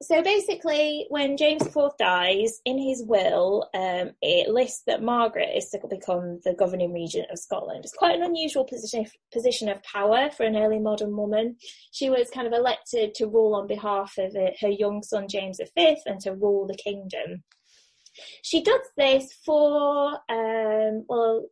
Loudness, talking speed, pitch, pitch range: -25 LUFS, 170 wpm, 225 Hz, 205-285 Hz